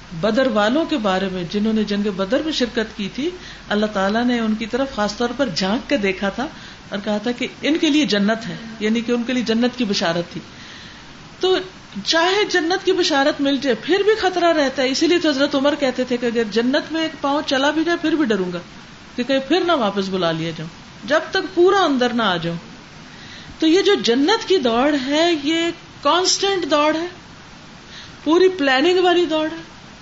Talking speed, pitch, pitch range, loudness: 210 wpm, 265 Hz, 215-320 Hz, -19 LUFS